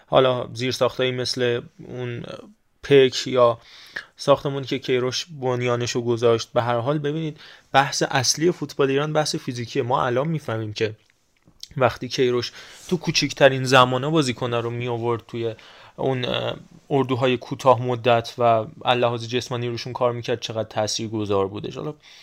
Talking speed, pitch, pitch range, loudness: 140 wpm, 125 Hz, 120-140 Hz, -22 LUFS